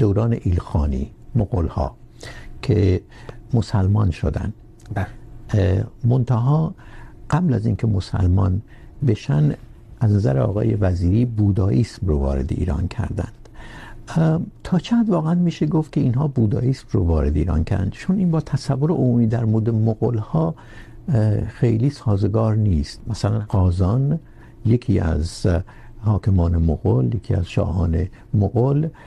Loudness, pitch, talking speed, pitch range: -21 LUFS, 110 Hz, 115 wpm, 100-125 Hz